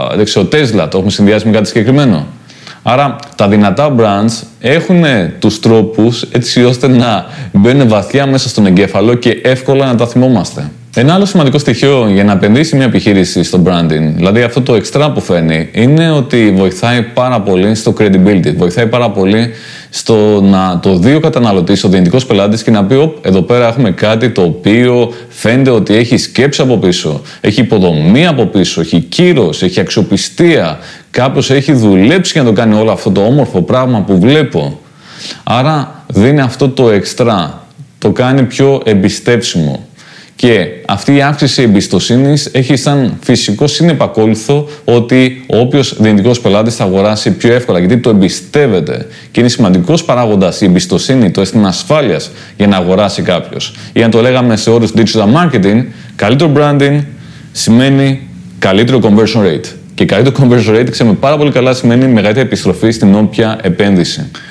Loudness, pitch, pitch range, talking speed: -9 LUFS, 120 Hz, 105-135 Hz, 160 wpm